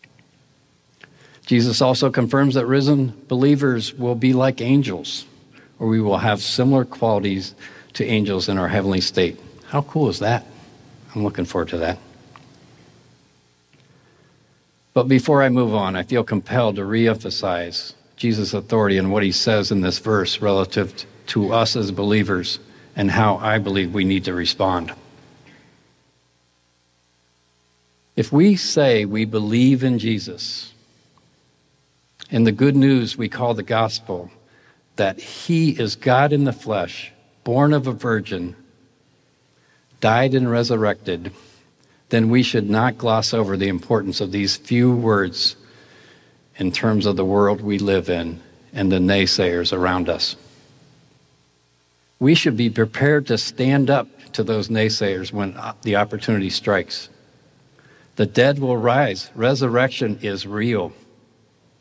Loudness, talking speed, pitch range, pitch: -19 LUFS, 135 wpm, 95-125 Hz, 110 Hz